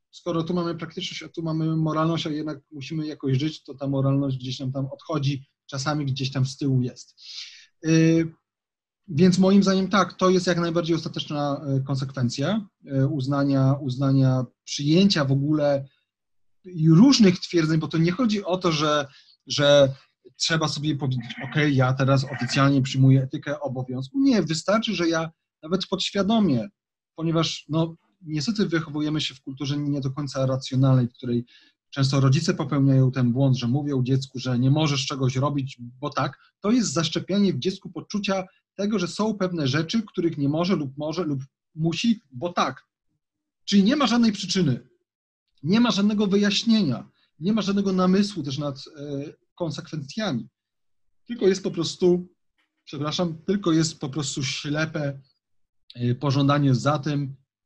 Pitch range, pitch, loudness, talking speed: 135-180 Hz, 150 Hz, -23 LUFS, 150 wpm